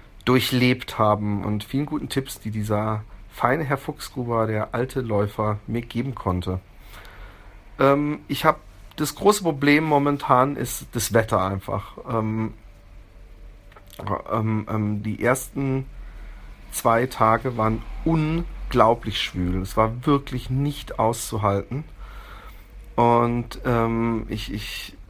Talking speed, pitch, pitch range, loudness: 110 wpm, 110 Hz, 100-130 Hz, -23 LUFS